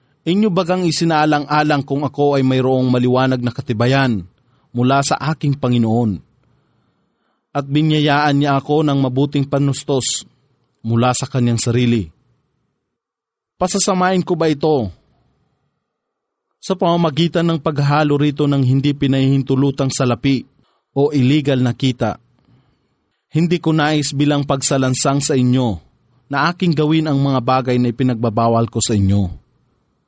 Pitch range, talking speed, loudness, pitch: 125-150 Hz, 120 wpm, -16 LUFS, 140 Hz